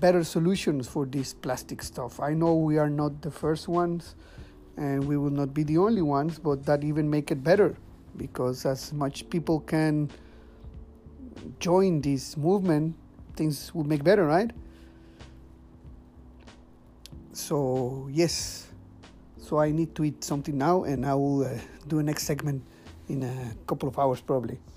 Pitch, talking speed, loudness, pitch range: 145 Hz, 155 wpm, -27 LUFS, 130-155 Hz